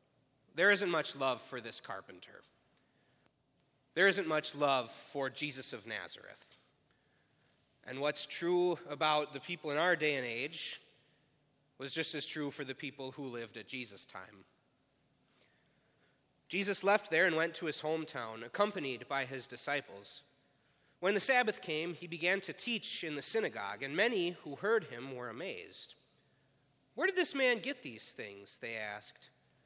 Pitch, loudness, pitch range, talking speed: 150 Hz, -35 LUFS, 135-180 Hz, 155 wpm